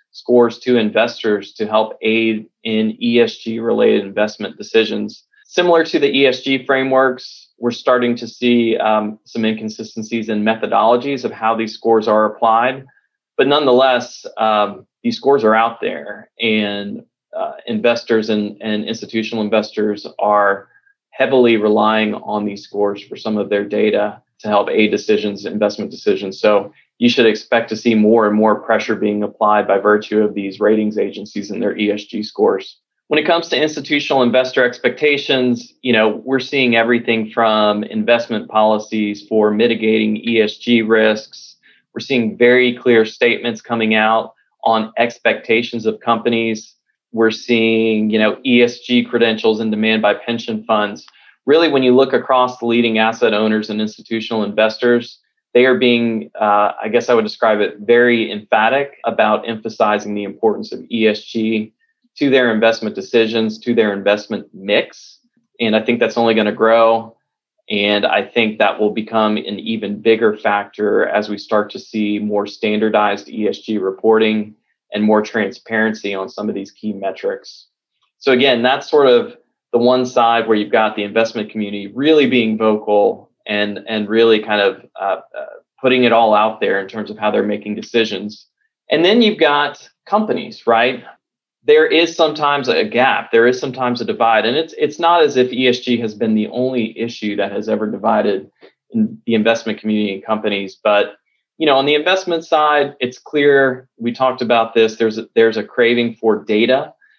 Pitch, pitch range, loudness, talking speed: 115 Hz, 110-125 Hz, -16 LUFS, 165 wpm